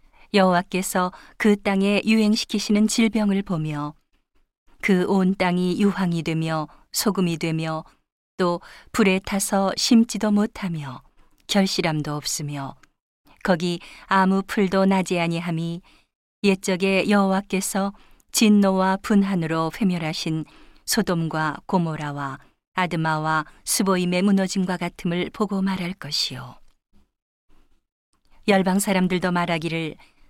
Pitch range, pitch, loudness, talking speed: 165-200 Hz, 185 Hz, -22 LUFS, 240 characters per minute